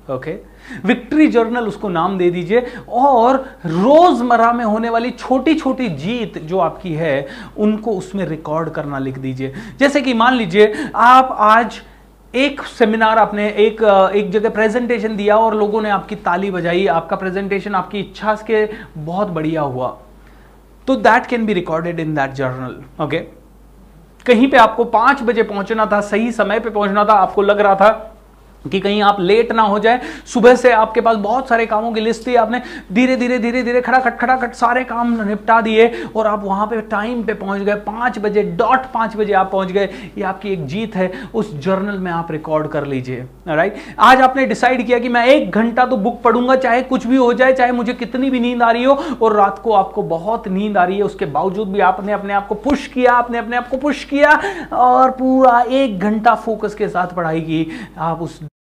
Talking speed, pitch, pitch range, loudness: 200 wpm, 215 Hz, 195-245 Hz, -15 LUFS